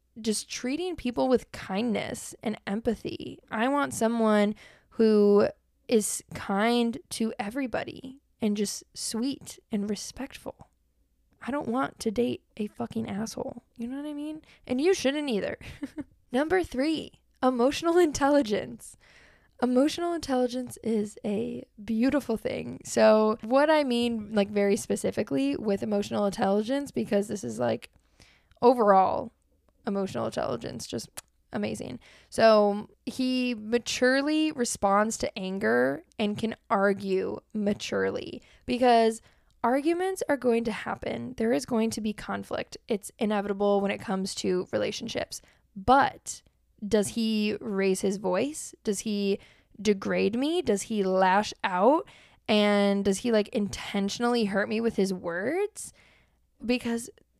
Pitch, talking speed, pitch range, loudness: 225 Hz, 125 wpm, 205-255 Hz, -27 LUFS